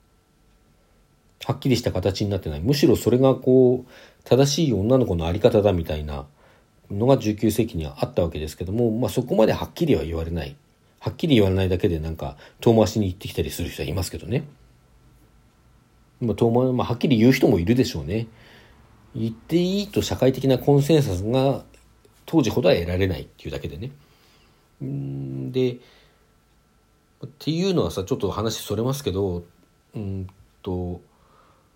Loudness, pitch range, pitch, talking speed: -22 LUFS, 90-130 Hz, 110 Hz, 355 characters per minute